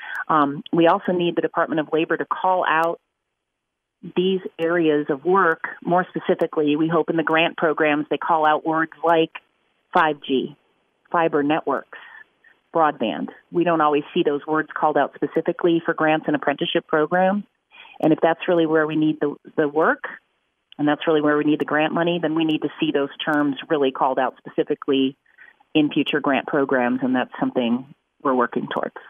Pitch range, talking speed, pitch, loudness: 150-170 Hz, 175 wpm, 160 Hz, -21 LUFS